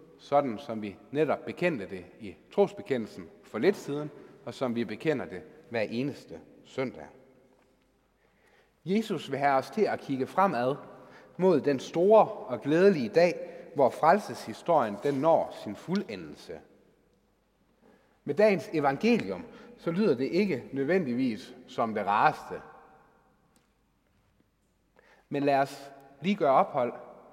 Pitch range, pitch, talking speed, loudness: 135-200 Hz, 155 Hz, 125 wpm, -28 LUFS